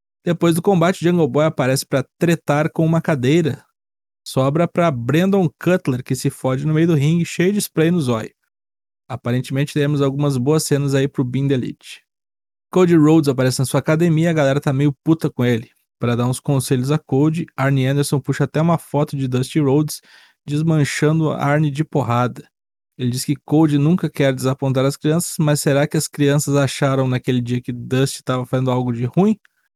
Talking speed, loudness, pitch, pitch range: 190 wpm, -18 LUFS, 145 Hz, 130-160 Hz